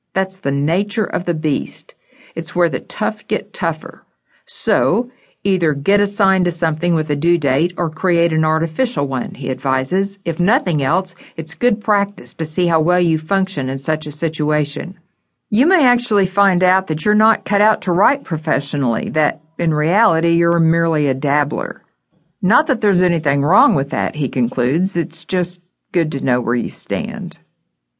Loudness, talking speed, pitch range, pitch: -17 LUFS, 175 wpm, 150-190 Hz, 170 Hz